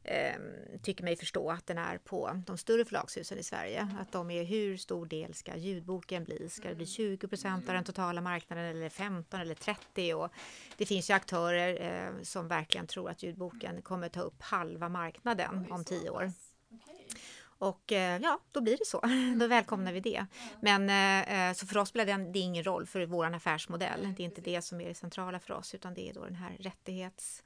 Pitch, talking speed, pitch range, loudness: 185 Hz, 195 wpm, 175-200 Hz, -35 LUFS